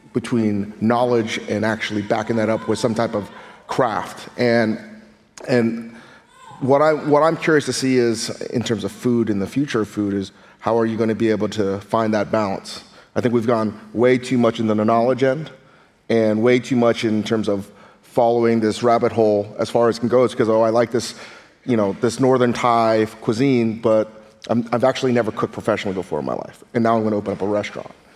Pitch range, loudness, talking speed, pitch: 110-120 Hz, -19 LUFS, 215 wpm, 115 Hz